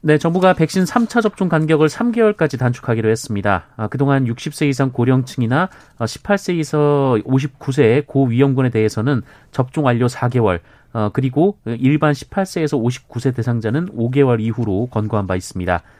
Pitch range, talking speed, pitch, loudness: 115-155 Hz, 310 characters per minute, 135 Hz, -17 LUFS